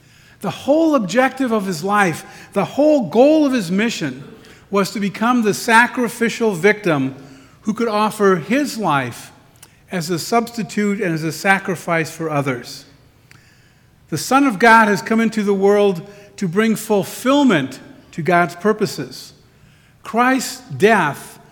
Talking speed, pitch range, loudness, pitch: 135 wpm, 150-225 Hz, -17 LUFS, 200 Hz